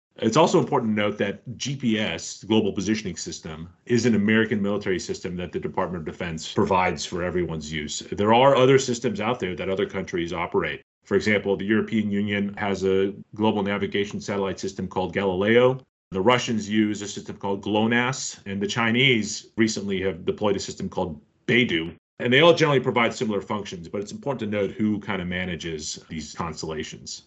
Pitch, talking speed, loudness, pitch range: 105 Hz, 185 wpm, -24 LUFS, 95-115 Hz